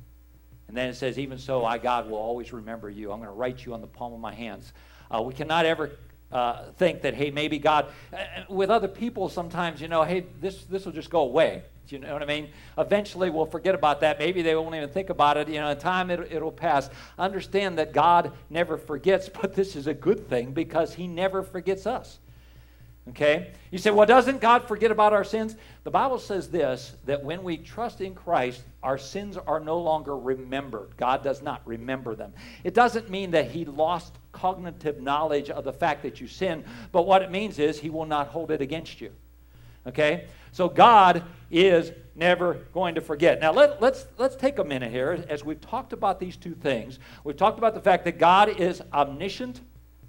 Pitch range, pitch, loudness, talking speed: 130-185 Hz, 155 Hz, -25 LUFS, 210 wpm